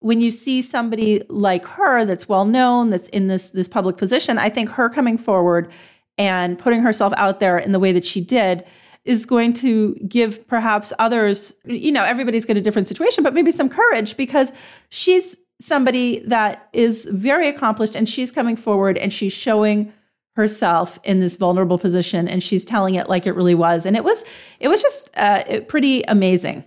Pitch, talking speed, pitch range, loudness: 215 Hz, 190 wpm, 190-245 Hz, -18 LUFS